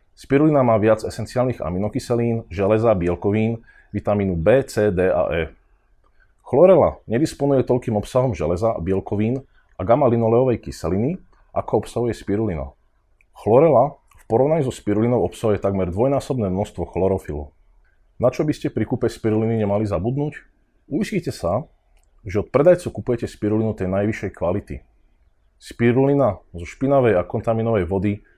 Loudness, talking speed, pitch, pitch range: -20 LUFS, 125 wpm, 110 Hz, 95-120 Hz